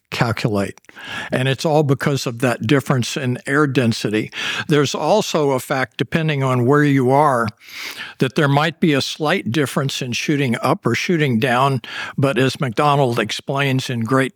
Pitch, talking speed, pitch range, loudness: 140 Hz, 165 wpm, 130-150 Hz, -18 LUFS